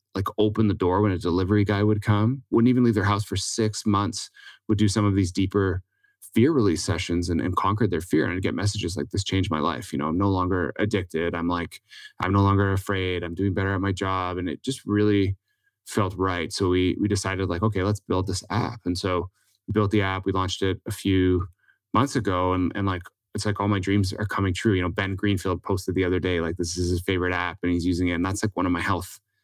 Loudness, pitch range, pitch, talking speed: -24 LUFS, 90-105 Hz, 95 Hz, 255 wpm